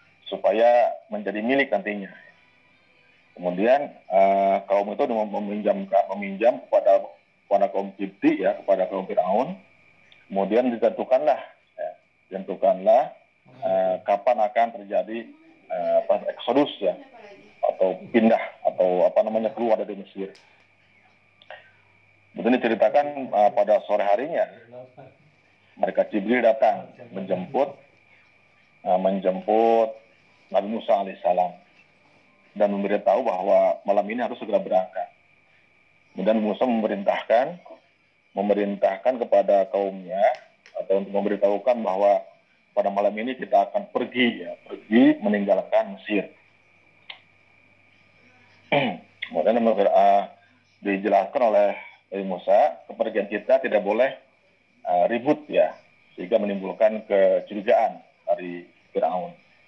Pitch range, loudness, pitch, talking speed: 100-135 Hz, -23 LUFS, 105 Hz, 100 wpm